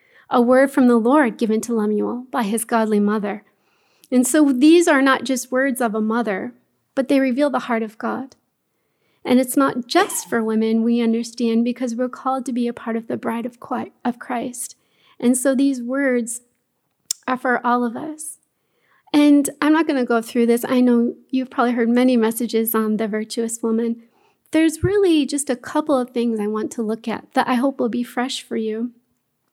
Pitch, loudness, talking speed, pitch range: 245 Hz, -19 LUFS, 195 wpm, 230-270 Hz